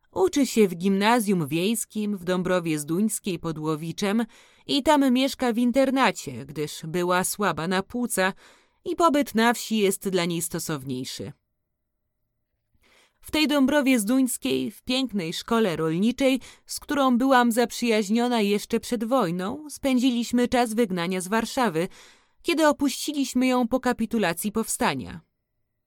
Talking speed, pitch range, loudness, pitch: 125 wpm, 175-250 Hz, -24 LUFS, 220 Hz